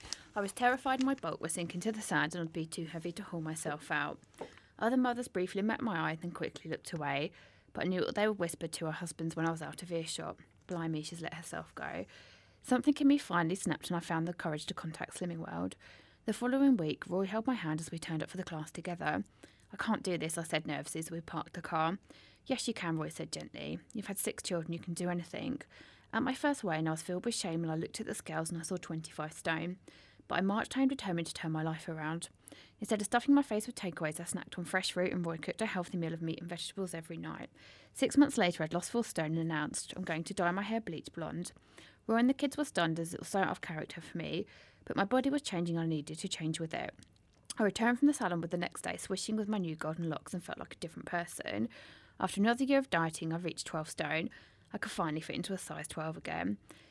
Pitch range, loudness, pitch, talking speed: 165-215 Hz, -36 LUFS, 175 Hz, 255 wpm